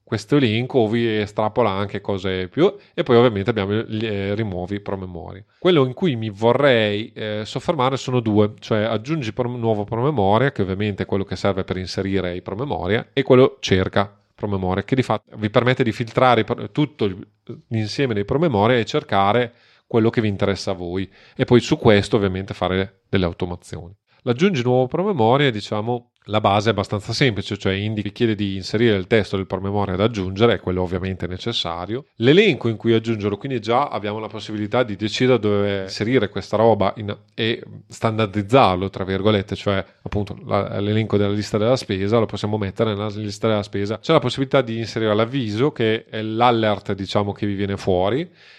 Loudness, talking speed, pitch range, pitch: -20 LUFS, 180 wpm, 100-120 Hz, 110 Hz